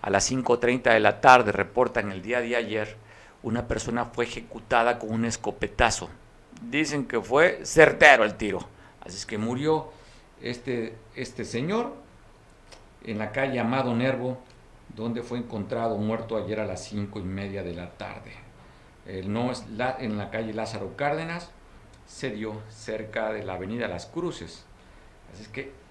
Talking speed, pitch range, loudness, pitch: 160 wpm, 105-125 Hz, -25 LUFS, 115 Hz